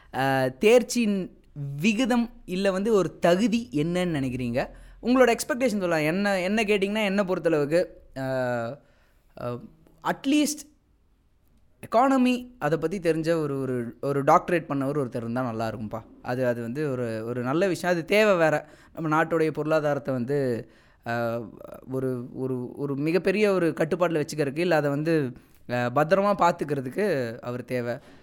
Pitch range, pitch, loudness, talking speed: 130-195 Hz, 155 Hz, -25 LUFS, 125 wpm